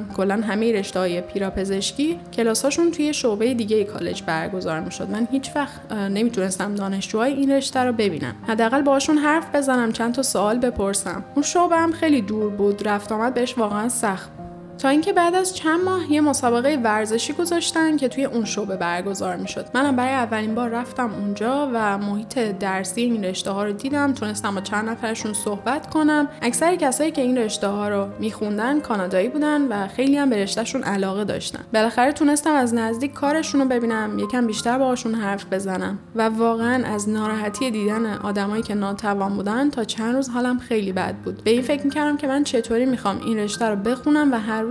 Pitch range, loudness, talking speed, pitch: 205-270 Hz, -22 LUFS, 185 wpm, 230 Hz